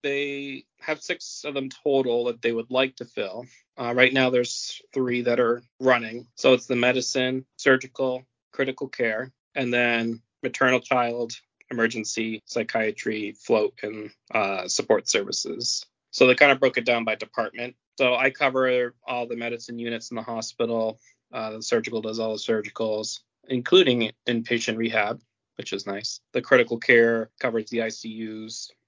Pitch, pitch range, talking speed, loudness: 120 Hz, 115-130 Hz, 160 wpm, -24 LUFS